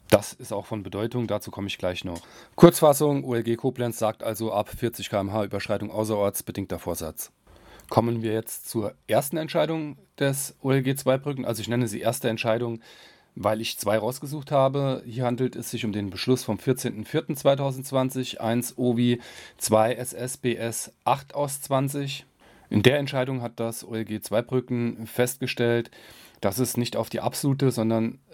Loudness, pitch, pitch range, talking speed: -26 LUFS, 120 Hz, 110-130 Hz, 155 wpm